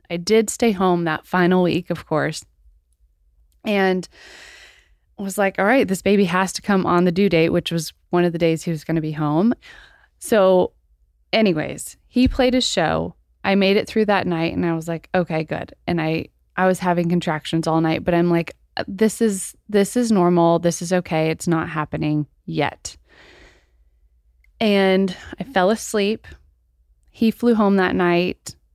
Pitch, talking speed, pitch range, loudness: 175 Hz, 175 wpm, 160-195 Hz, -20 LUFS